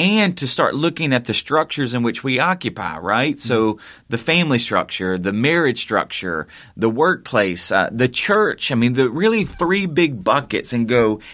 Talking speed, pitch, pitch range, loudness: 175 wpm, 130 Hz, 115-165 Hz, -18 LUFS